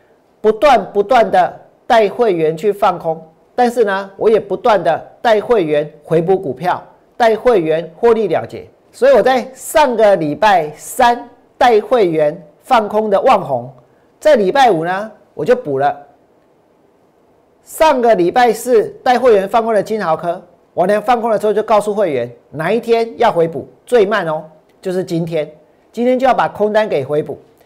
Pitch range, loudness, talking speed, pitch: 165-240 Hz, -14 LUFS, 235 characters per minute, 210 Hz